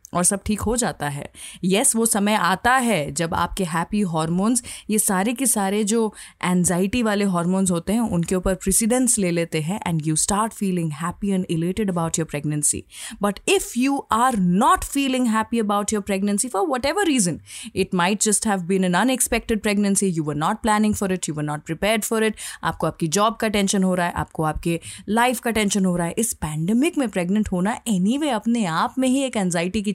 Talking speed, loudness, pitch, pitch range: 210 wpm, -21 LUFS, 200 Hz, 175-225 Hz